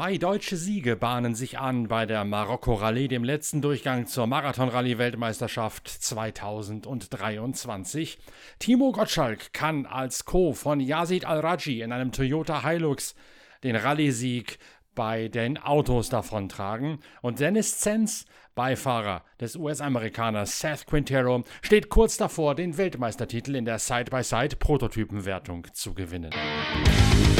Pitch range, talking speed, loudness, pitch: 115-150 Hz, 110 wpm, -27 LUFS, 125 Hz